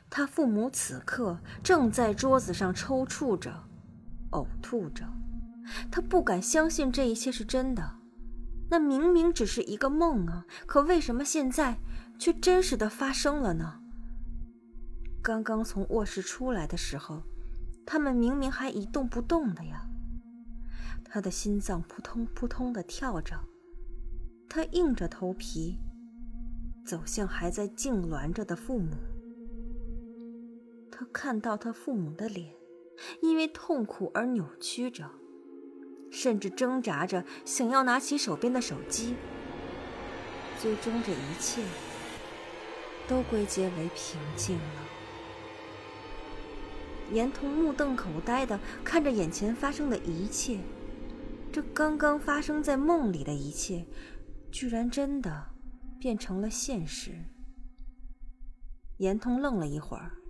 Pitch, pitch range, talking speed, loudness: 235 Hz, 185-270 Hz, 180 characters per minute, -31 LUFS